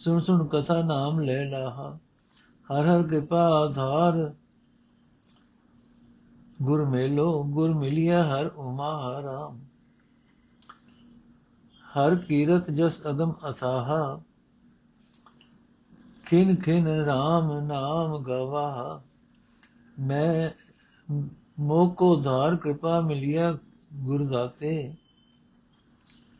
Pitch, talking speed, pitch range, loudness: 150 Hz, 75 wpm, 140-170 Hz, -26 LUFS